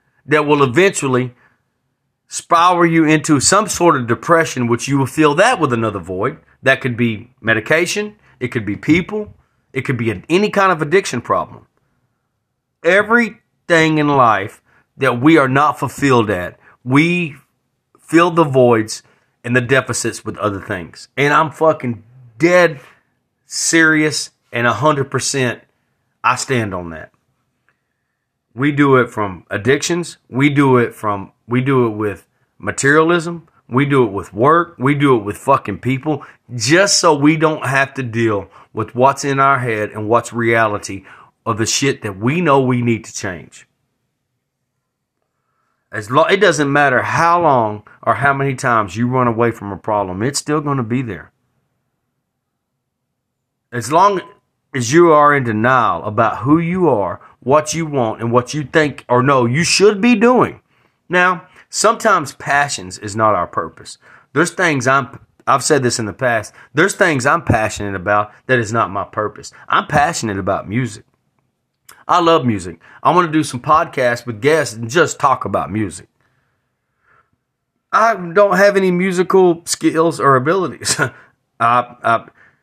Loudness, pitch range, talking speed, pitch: -15 LUFS, 120-155 Hz, 160 wpm, 130 Hz